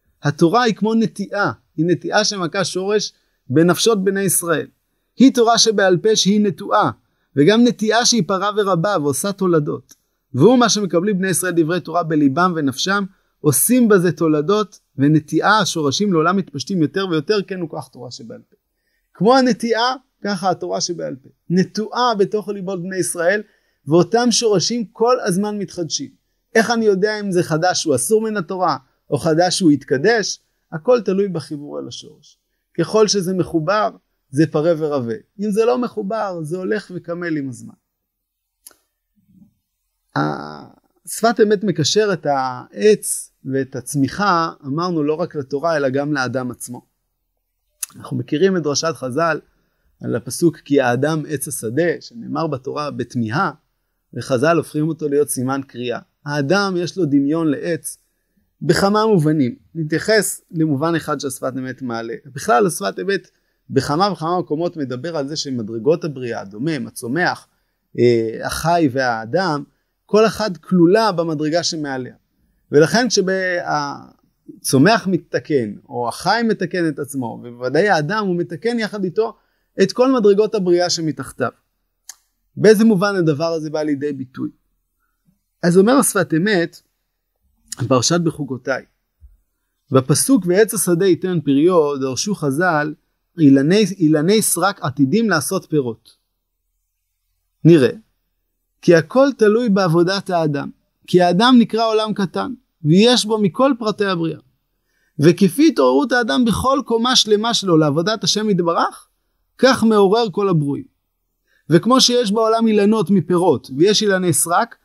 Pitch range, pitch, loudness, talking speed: 145-210 Hz, 175 Hz, -17 LUFS, 130 wpm